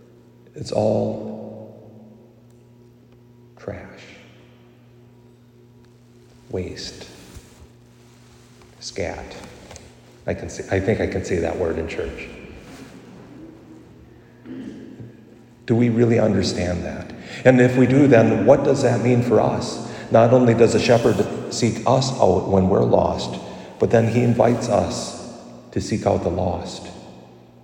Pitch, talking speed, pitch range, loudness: 115 Hz, 115 wpm, 95-120 Hz, -19 LUFS